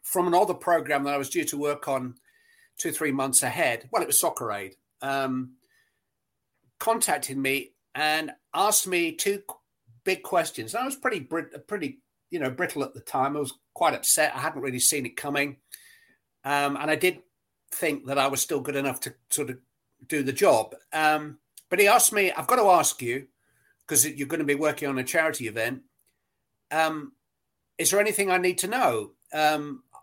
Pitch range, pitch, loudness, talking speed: 135-170 Hz, 145 Hz, -25 LUFS, 190 wpm